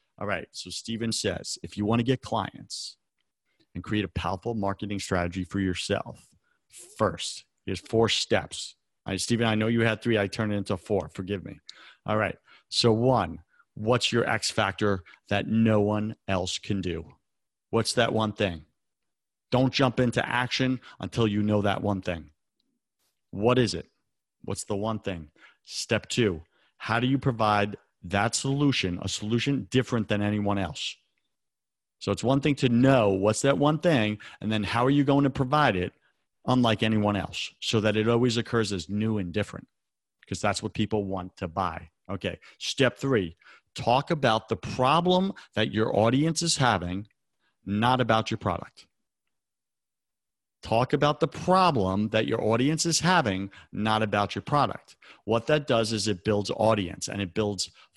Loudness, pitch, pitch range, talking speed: -26 LUFS, 110 Hz, 100-125 Hz, 170 wpm